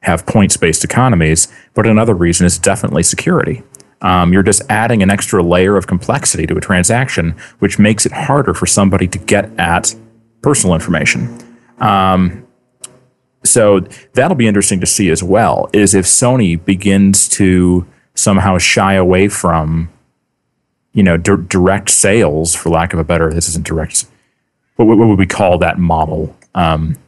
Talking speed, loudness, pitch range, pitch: 155 wpm, -11 LUFS, 85-110 Hz, 95 Hz